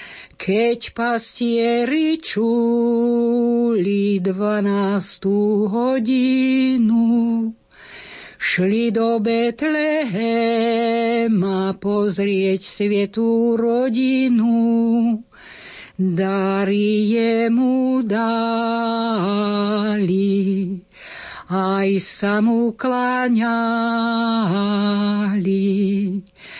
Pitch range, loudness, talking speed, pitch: 200-235 Hz, -19 LUFS, 40 wpm, 230 Hz